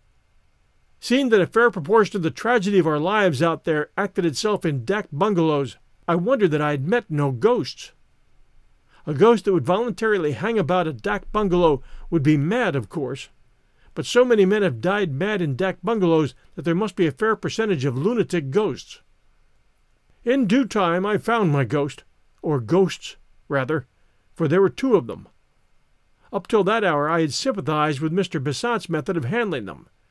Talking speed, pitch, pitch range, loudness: 180 wpm, 185 Hz, 155-210 Hz, -21 LUFS